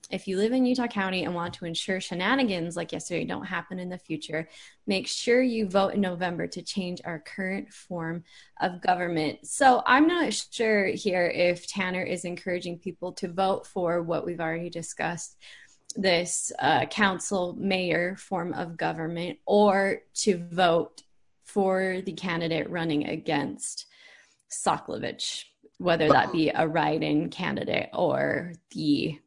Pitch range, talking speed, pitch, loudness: 170-195 Hz, 150 wpm, 180 Hz, -27 LUFS